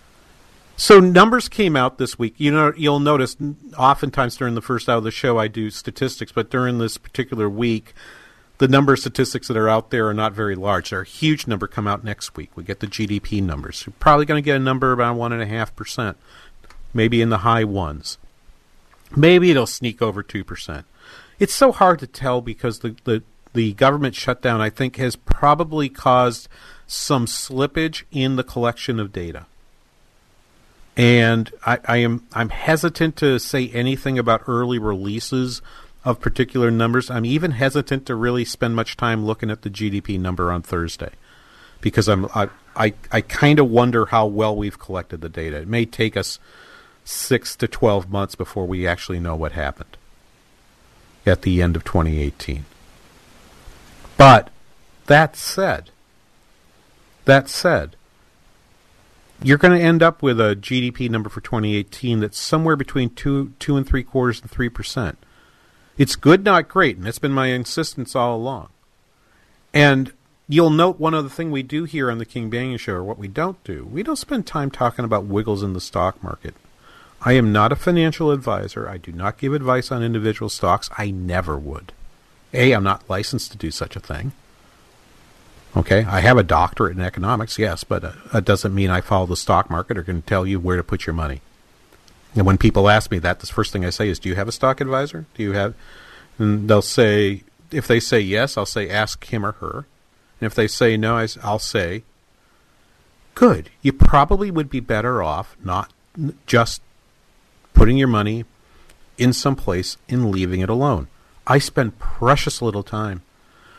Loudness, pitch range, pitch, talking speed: -19 LUFS, 100-135 Hz, 115 Hz, 180 wpm